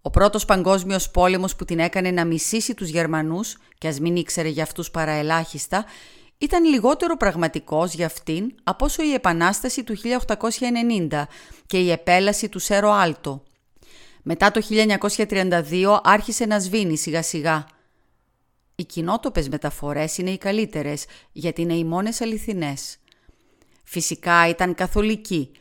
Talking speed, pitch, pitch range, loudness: 135 wpm, 180 Hz, 160-215 Hz, -21 LUFS